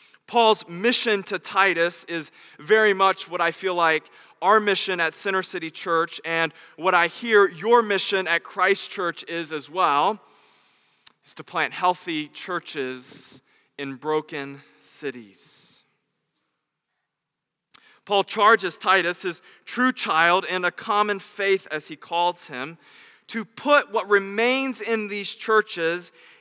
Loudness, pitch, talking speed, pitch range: -22 LUFS, 185 Hz, 130 wpm, 165-210 Hz